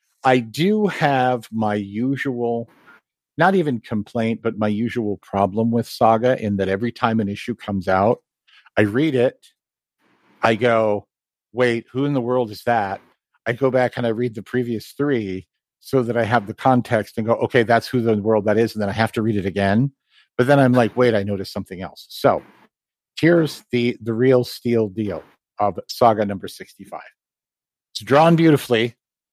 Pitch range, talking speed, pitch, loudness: 110-125 Hz, 180 wpm, 115 Hz, -20 LUFS